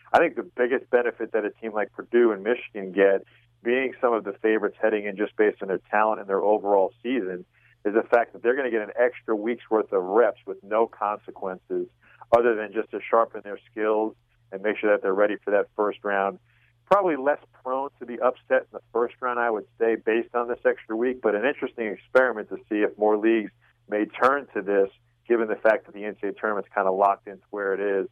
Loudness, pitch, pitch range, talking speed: -25 LUFS, 110 Hz, 105-125 Hz, 230 wpm